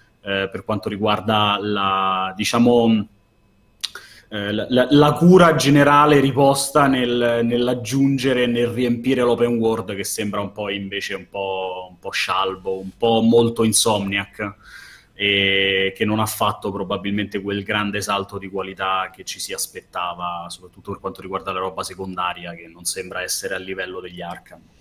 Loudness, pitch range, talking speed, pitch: -19 LUFS, 95-120 Hz, 150 wpm, 100 Hz